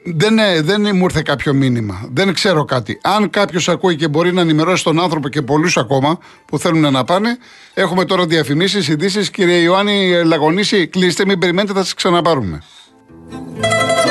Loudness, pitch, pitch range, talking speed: -14 LUFS, 175 Hz, 150-190 Hz, 165 wpm